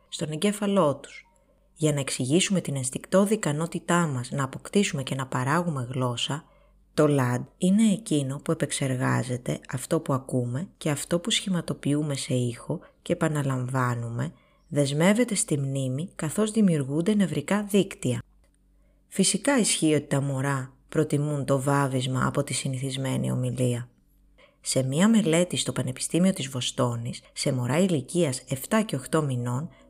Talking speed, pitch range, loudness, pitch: 130 wpm, 130-175 Hz, -26 LUFS, 145 Hz